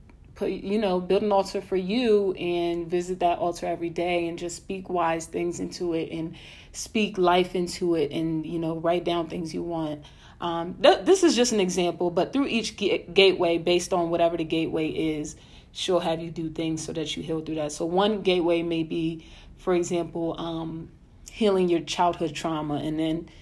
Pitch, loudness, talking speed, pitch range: 170 Hz, -26 LUFS, 195 wpm, 165-180 Hz